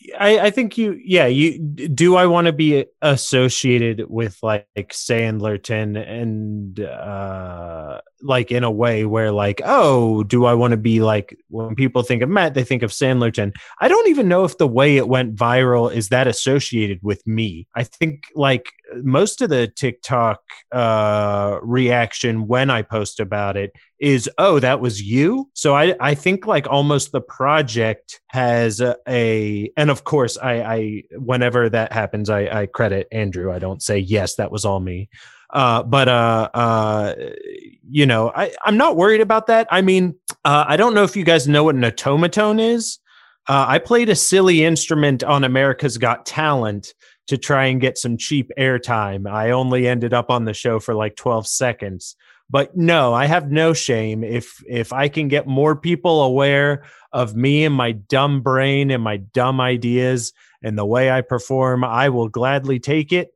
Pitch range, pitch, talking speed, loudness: 110-145 Hz, 125 Hz, 180 wpm, -17 LUFS